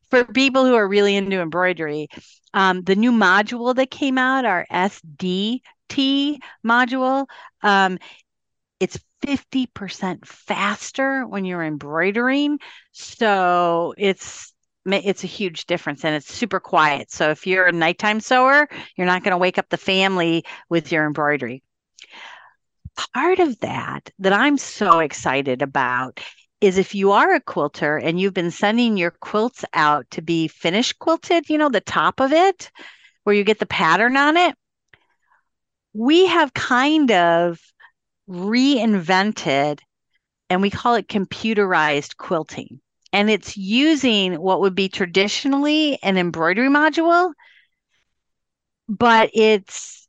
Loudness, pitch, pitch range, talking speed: -19 LUFS, 200 Hz, 175-260 Hz, 135 wpm